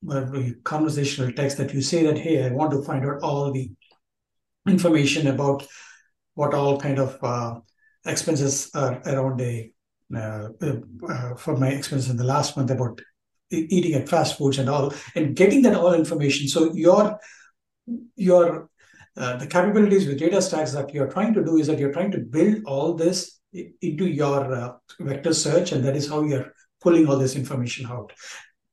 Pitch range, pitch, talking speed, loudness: 135-170 Hz, 145 Hz, 175 wpm, -22 LUFS